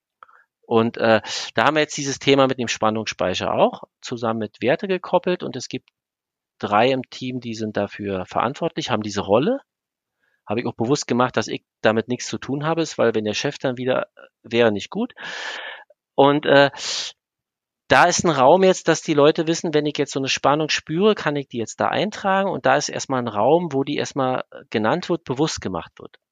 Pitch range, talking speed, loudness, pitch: 115-155 Hz, 205 wpm, -21 LUFS, 135 Hz